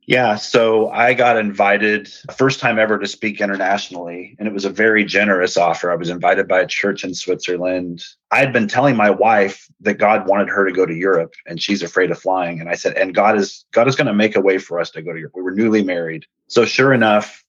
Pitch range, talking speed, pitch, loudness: 90-110 Hz, 240 wpm, 100 Hz, -16 LUFS